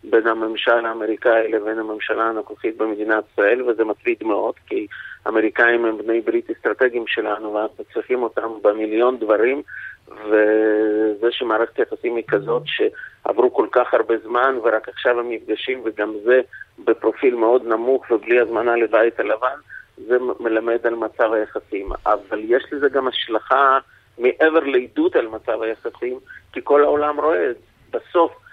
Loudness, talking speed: -19 LUFS, 140 wpm